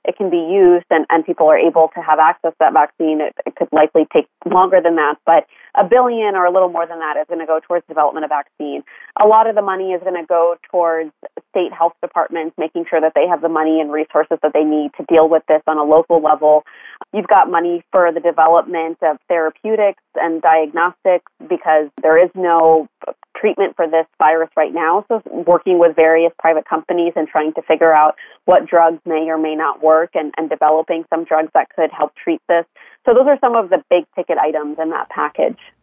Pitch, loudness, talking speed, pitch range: 165 Hz, -15 LUFS, 225 wpm, 155-175 Hz